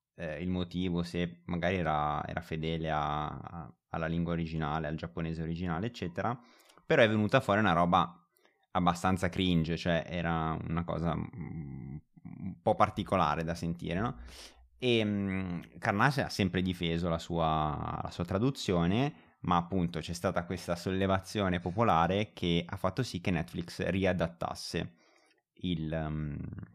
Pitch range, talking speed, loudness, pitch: 80-95 Hz, 135 wpm, -32 LUFS, 85 Hz